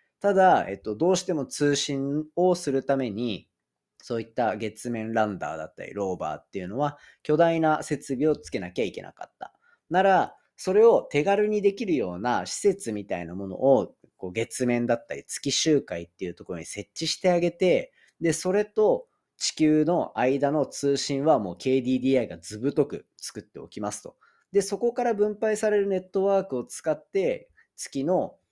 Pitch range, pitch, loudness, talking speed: 125-200 Hz, 150 Hz, -26 LUFS, 340 characters per minute